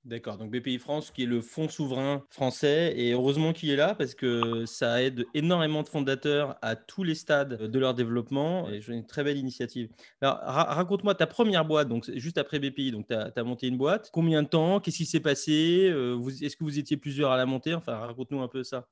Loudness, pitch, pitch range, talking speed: -28 LUFS, 140 Hz, 125-155 Hz, 230 wpm